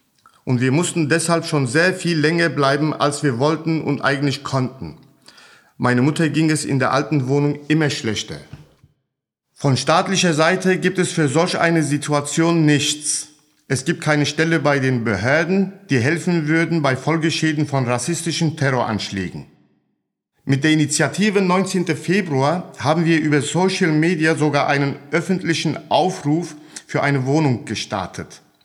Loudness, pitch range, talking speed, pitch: -18 LUFS, 140-165 Hz, 140 wpm, 150 Hz